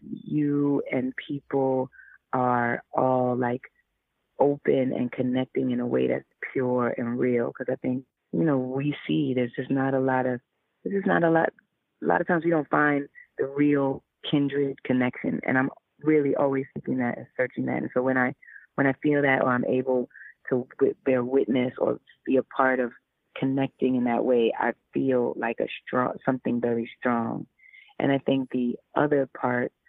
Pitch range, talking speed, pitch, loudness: 125-140 Hz, 185 wpm, 130 Hz, -26 LUFS